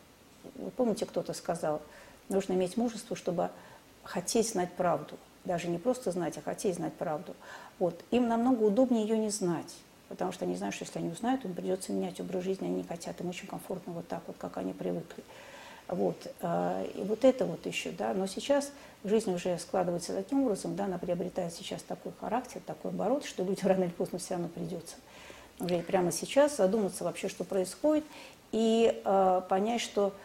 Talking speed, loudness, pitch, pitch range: 180 wpm, -32 LUFS, 190 Hz, 175-220 Hz